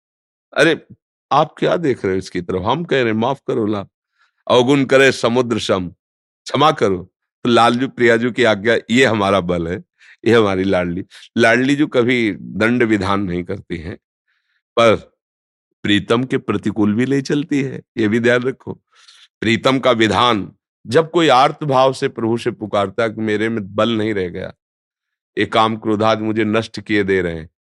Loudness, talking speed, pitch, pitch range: -17 LUFS, 175 wpm, 110 Hz, 100-125 Hz